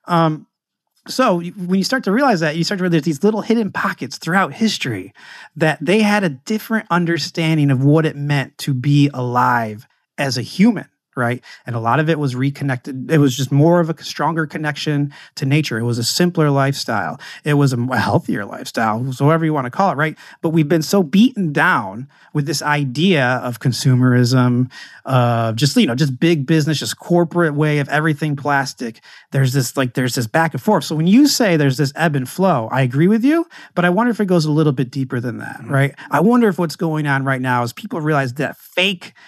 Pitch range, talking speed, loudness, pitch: 135-175 Hz, 215 wpm, -17 LUFS, 150 Hz